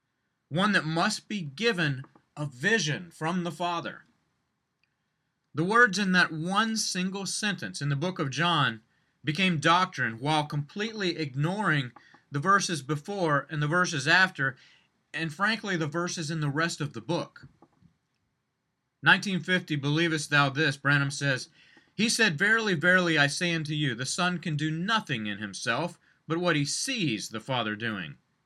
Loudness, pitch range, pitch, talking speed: -27 LUFS, 145-185 Hz, 165 Hz, 150 wpm